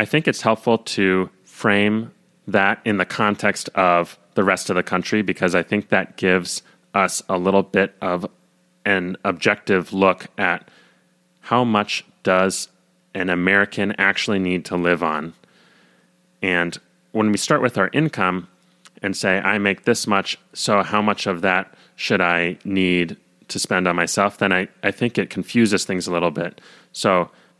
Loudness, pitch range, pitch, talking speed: -20 LUFS, 90-105 Hz, 95 Hz, 165 wpm